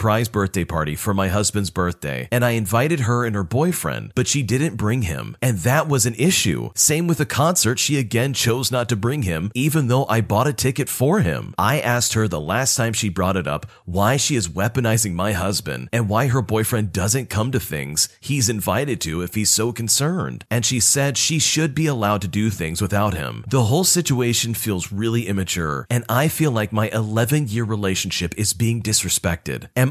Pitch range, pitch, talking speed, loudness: 100-130 Hz, 115 Hz, 210 wpm, -20 LUFS